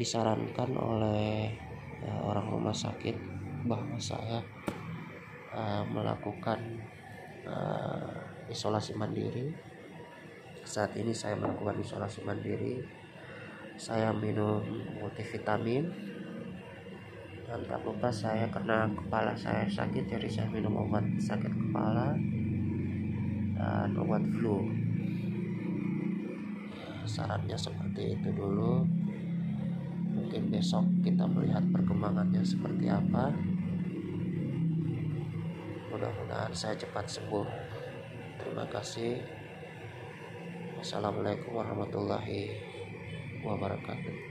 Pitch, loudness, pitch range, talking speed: 125 Hz, -34 LUFS, 110-175 Hz, 80 wpm